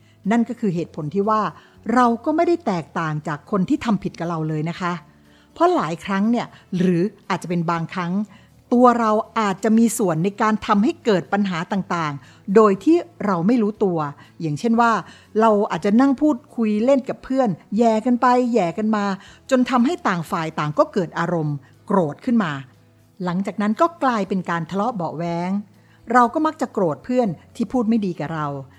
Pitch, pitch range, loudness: 205 Hz, 170-235 Hz, -20 LUFS